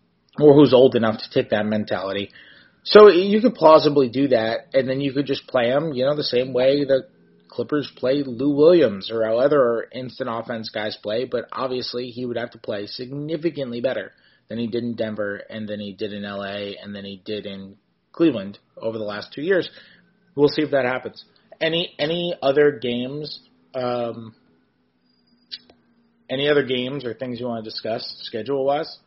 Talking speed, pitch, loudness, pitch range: 185 wpm, 125 Hz, -21 LUFS, 110-145 Hz